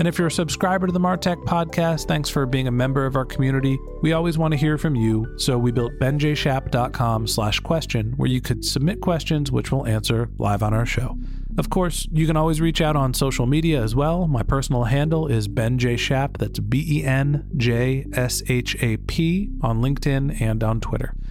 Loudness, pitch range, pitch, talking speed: -22 LUFS, 120-155 Hz, 135 Hz, 200 wpm